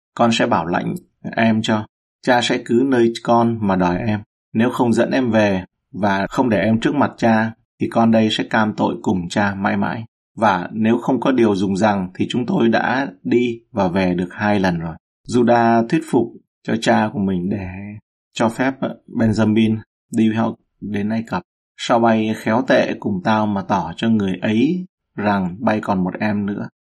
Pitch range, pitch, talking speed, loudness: 100-115 Hz, 110 Hz, 195 wpm, -18 LUFS